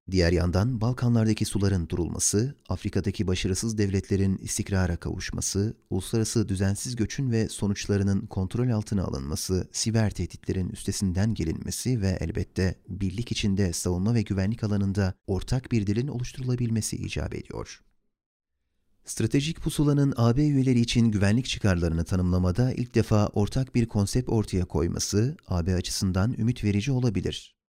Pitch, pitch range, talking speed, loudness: 105 Hz, 95-115 Hz, 120 wpm, -27 LUFS